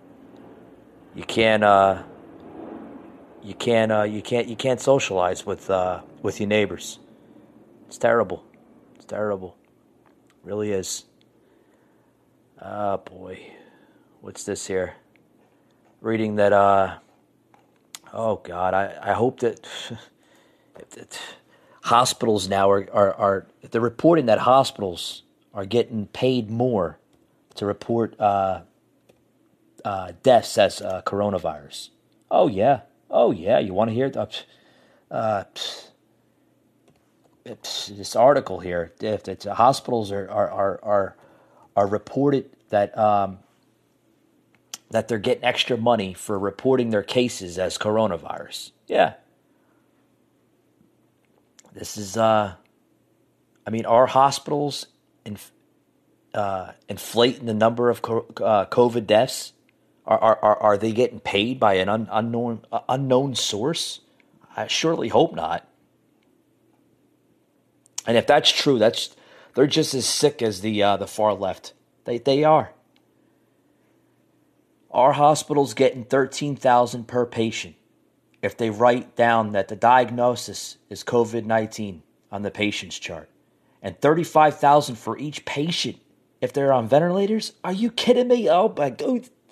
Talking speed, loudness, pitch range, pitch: 125 wpm, -22 LUFS, 100-125 Hz, 110 Hz